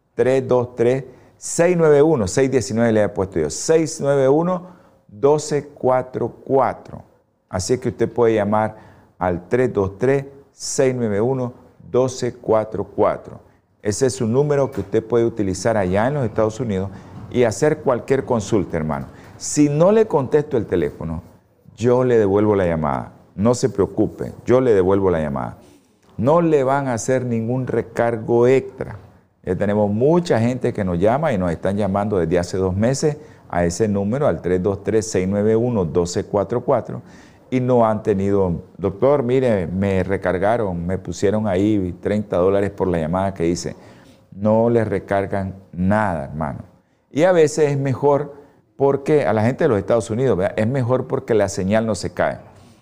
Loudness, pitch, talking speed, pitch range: -19 LUFS, 110 Hz, 140 wpm, 95-130 Hz